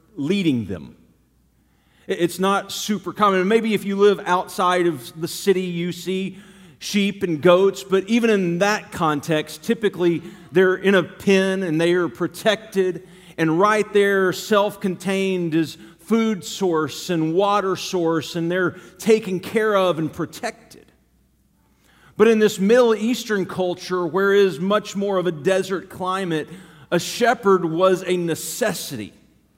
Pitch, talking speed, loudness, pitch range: 185 Hz, 140 wpm, -20 LUFS, 170-200 Hz